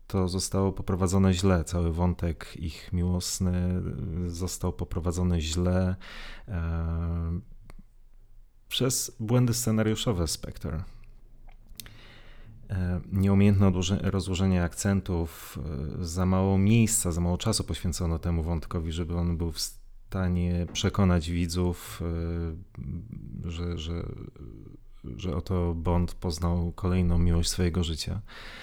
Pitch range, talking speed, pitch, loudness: 85-100 Hz, 105 wpm, 90 Hz, -28 LUFS